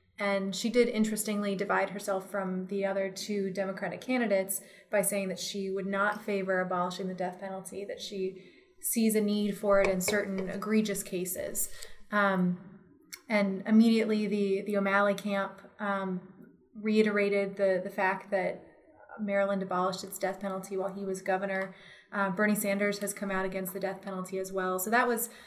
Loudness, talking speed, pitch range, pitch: -31 LUFS, 165 wpm, 190-205 Hz, 195 Hz